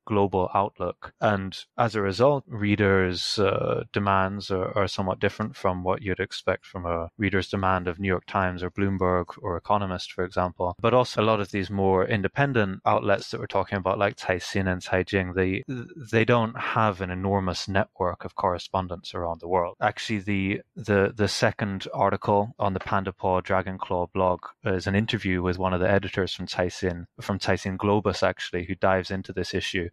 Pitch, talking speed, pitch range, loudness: 95 Hz, 185 wpm, 95-105 Hz, -26 LUFS